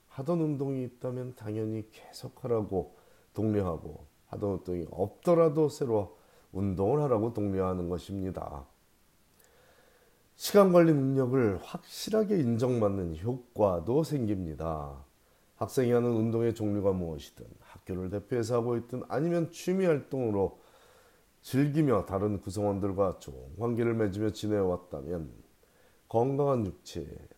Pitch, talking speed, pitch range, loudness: 110 Hz, 285 characters per minute, 95-130 Hz, -30 LUFS